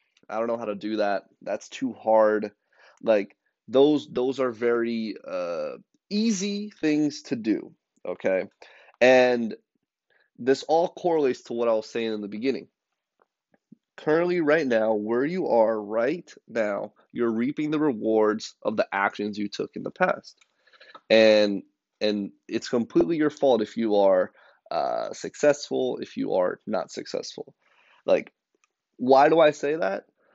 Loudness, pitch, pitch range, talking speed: -25 LUFS, 125 Hz, 110-160 Hz, 150 wpm